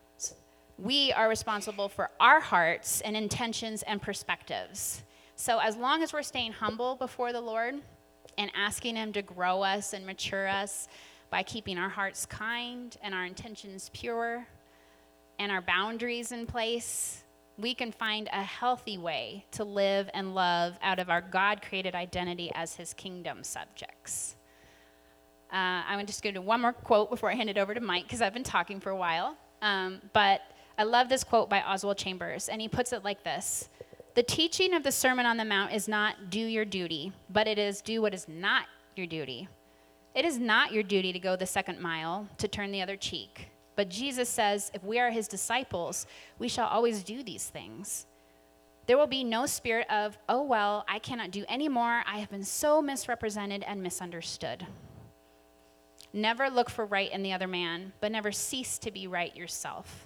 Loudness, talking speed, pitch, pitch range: -31 LUFS, 185 wpm, 205 Hz, 180-230 Hz